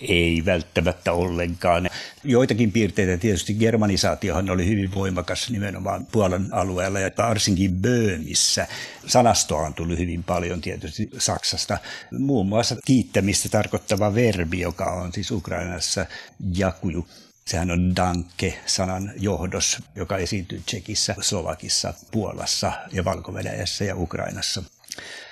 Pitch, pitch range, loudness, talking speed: 95 Hz, 90-105 Hz, -23 LUFS, 110 wpm